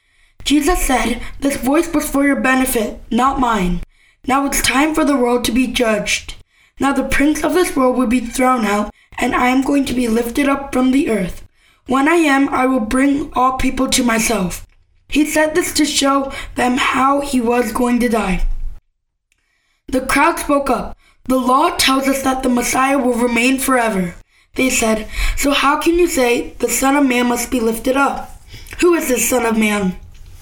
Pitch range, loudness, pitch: 240-275 Hz, -16 LUFS, 260 Hz